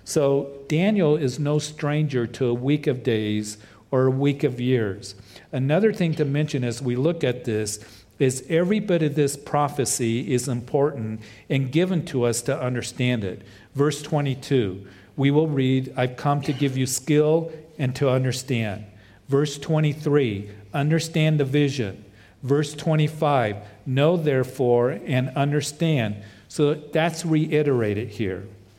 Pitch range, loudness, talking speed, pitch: 115-150 Hz, -23 LUFS, 140 wpm, 135 Hz